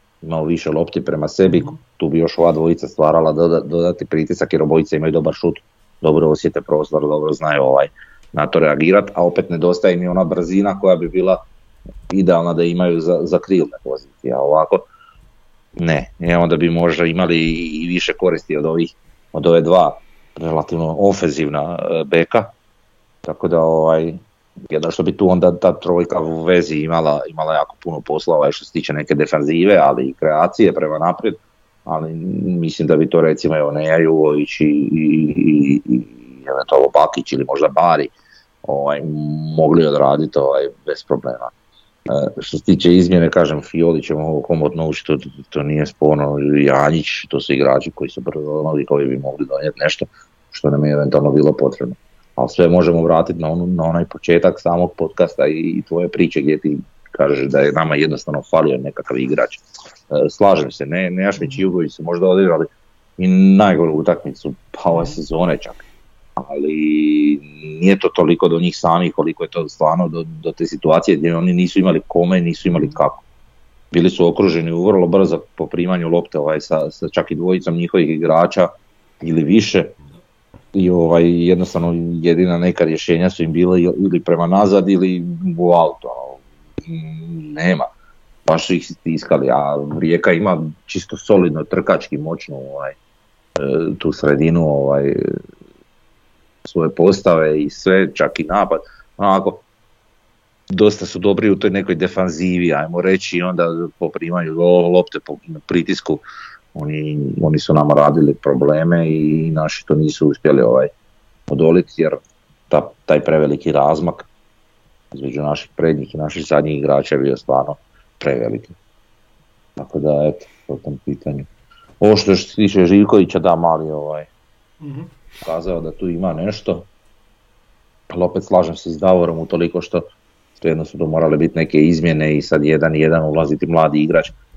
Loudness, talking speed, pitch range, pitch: -16 LUFS, 160 wpm, 75-90 Hz, 85 Hz